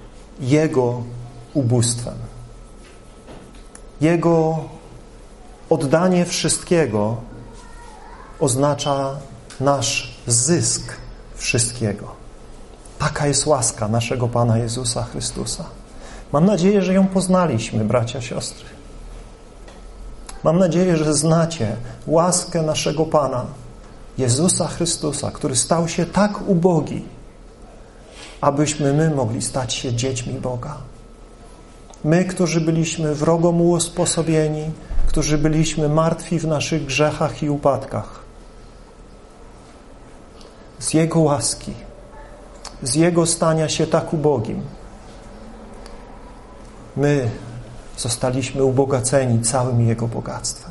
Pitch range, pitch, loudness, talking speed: 120-160 Hz, 145 Hz, -19 LUFS, 85 wpm